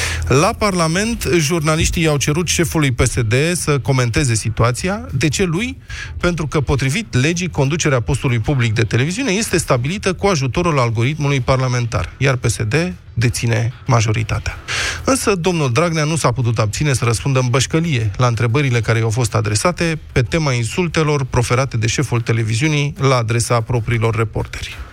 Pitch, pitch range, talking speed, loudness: 135 Hz, 115-155 Hz, 145 wpm, -17 LUFS